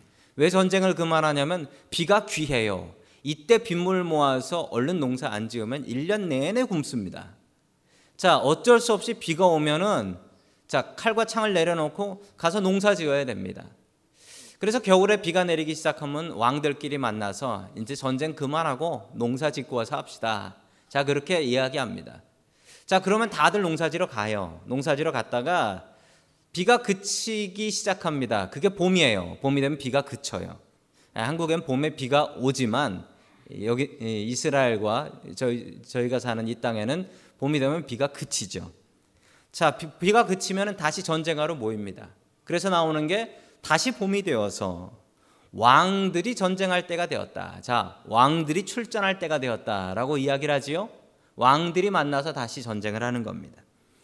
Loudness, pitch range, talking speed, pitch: -25 LUFS, 125-185 Hz, 305 characters per minute, 150 Hz